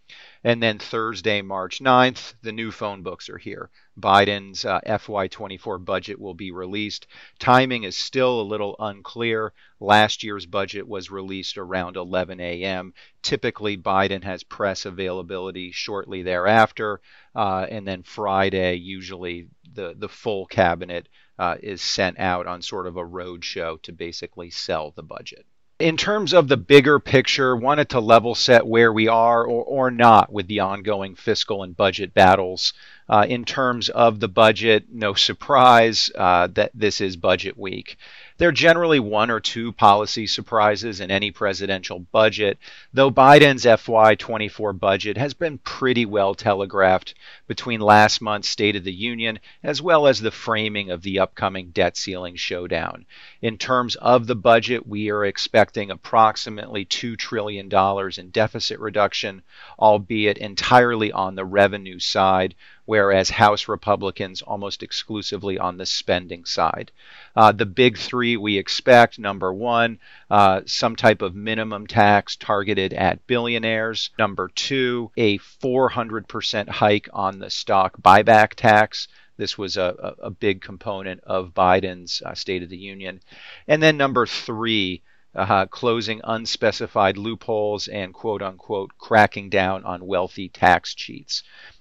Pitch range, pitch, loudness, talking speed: 95-115 Hz, 105 Hz, -20 LUFS, 145 wpm